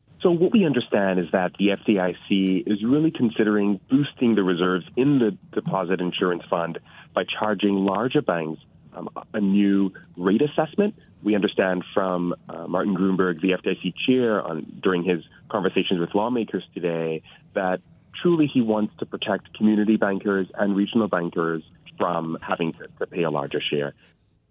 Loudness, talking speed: -23 LUFS, 155 wpm